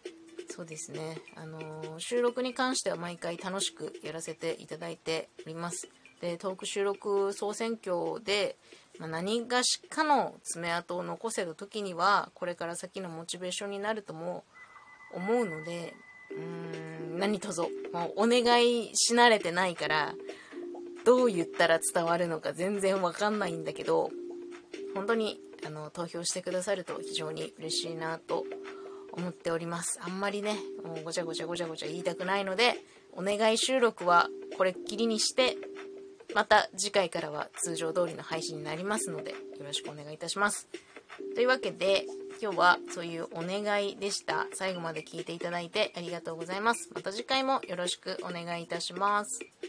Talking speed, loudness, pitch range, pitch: 345 characters per minute, -31 LUFS, 170-235 Hz, 190 Hz